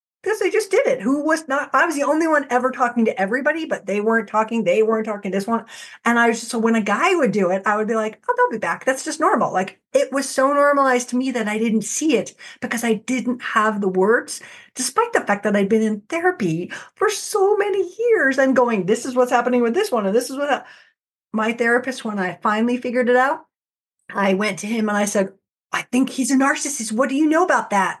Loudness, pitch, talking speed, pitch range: -19 LUFS, 250 Hz, 255 wpm, 220-295 Hz